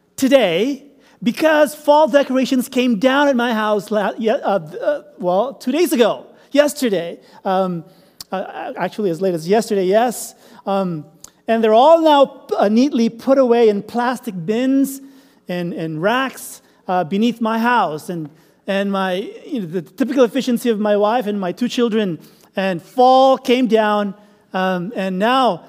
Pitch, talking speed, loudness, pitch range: 230 Hz, 145 wpm, -17 LUFS, 195-260 Hz